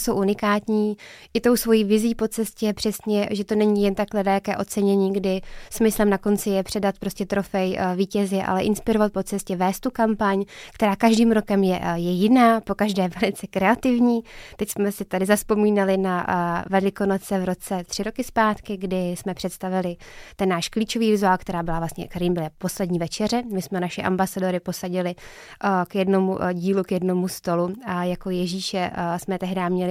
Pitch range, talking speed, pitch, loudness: 185-210 Hz, 175 wpm, 195 Hz, -23 LUFS